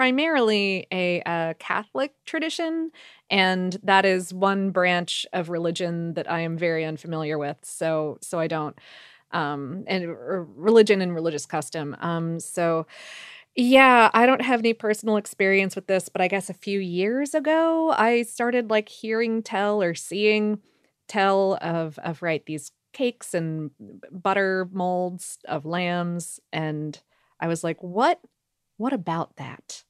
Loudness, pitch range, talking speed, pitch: -24 LUFS, 165-215 Hz, 145 wpm, 185 Hz